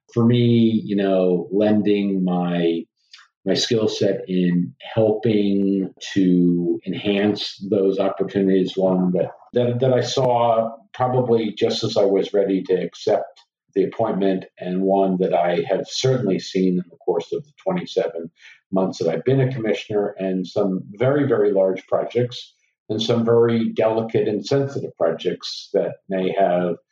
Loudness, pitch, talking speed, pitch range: -21 LUFS, 100 Hz, 145 wpm, 95-115 Hz